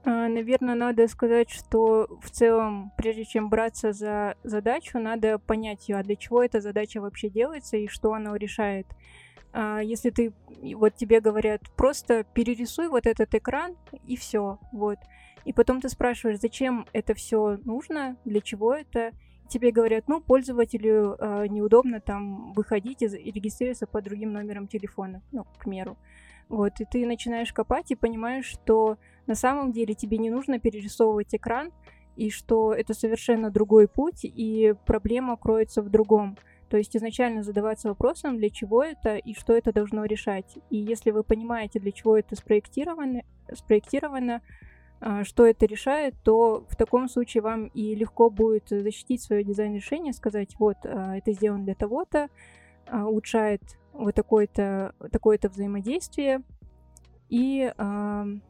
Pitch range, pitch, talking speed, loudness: 210-240 Hz, 225 Hz, 145 wpm, -26 LUFS